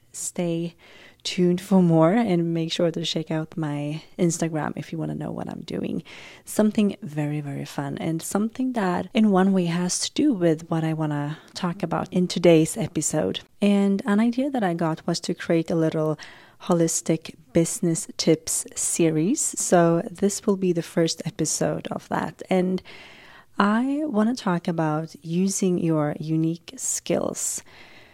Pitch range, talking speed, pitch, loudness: 160-195 Hz, 165 wpm, 170 Hz, -24 LUFS